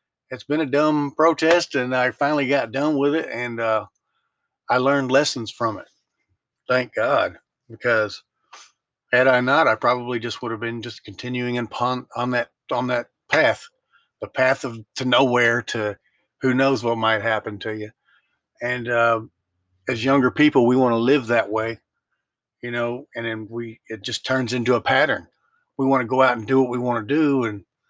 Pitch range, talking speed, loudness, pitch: 115-135 Hz, 190 wpm, -21 LUFS, 125 Hz